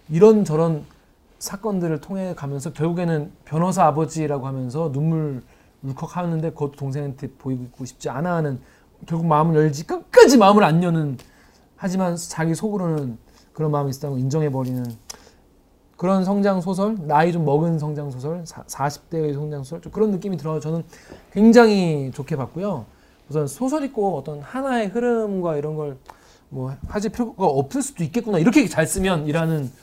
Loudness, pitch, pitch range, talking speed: -21 LUFS, 160 Hz, 145-190 Hz, 335 characters per minute